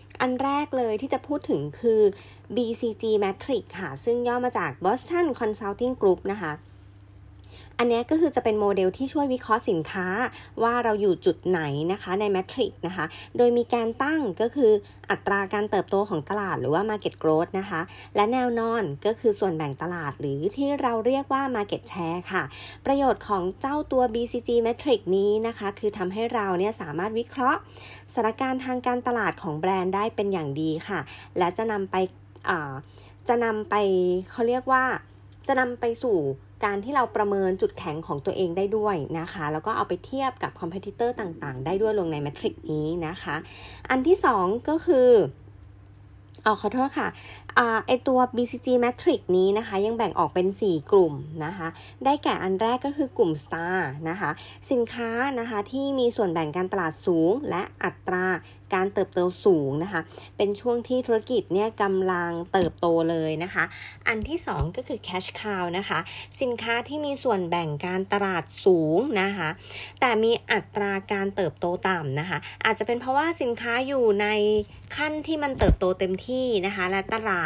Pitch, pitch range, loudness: 205 Hz, 175-240 Hz, -26 LUFS